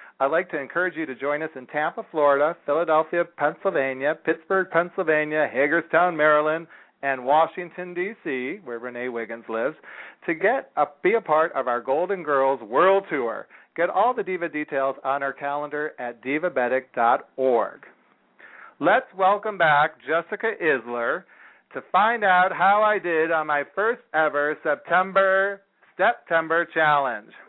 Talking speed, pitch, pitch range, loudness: 140 wpm, 155 Hz, 140-180 Hz, -23 LUFS